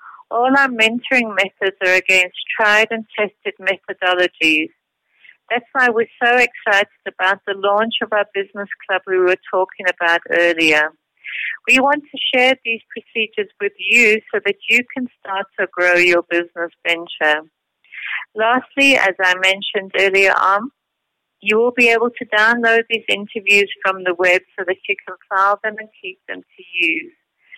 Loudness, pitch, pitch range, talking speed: -16 LUFS, 200 Hz, 185-230 Hz, 160 wpm